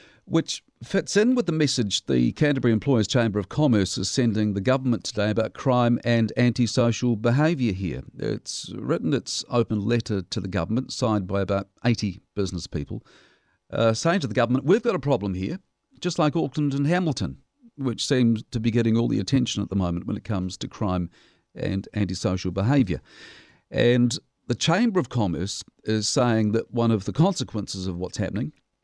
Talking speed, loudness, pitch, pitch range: 180 wpm, -24 LUFS, 115 Hz, 100-130 Hz